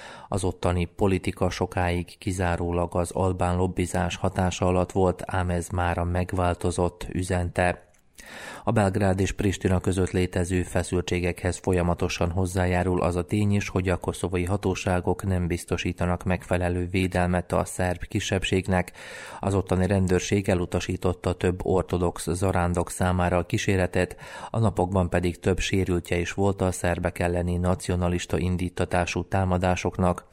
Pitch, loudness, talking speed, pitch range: 90 Hz, -26 LUFS, 125 wpm, 90-95 Hz